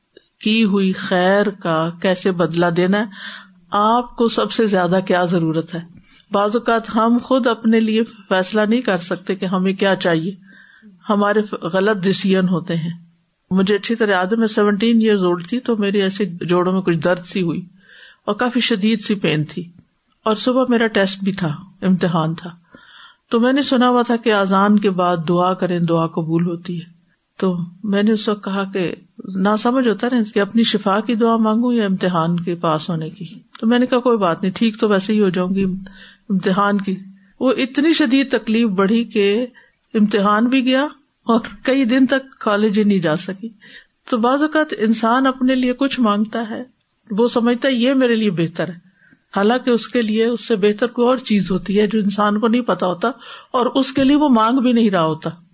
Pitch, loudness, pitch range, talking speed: 210 Hz, -17 LUFS, 185-235 Hz, 200 wpm